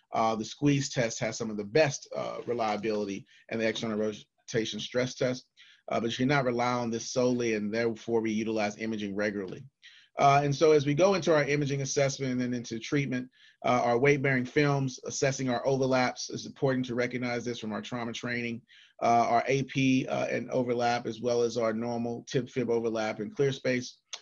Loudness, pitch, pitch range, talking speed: -29 LUFS, 120 Hz, 115-135 Hz, 200 wpm